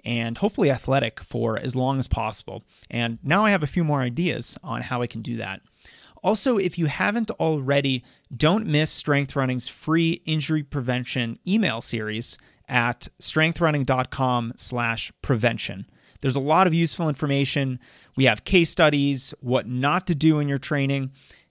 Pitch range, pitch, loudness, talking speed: 125-160 Hz, 140 Hz, -23 LUFS, 155 wpm